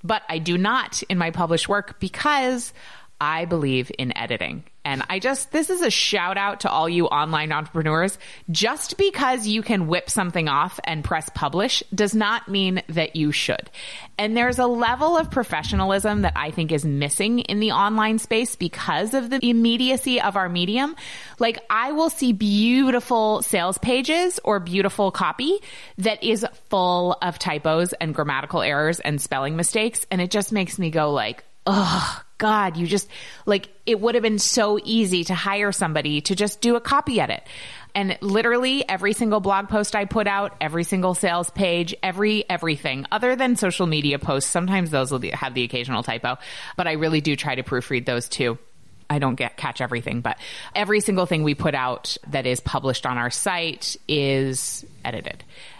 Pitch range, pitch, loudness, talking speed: 155-220 Hz, 190 Hz, -22 LUFS, 180 wpm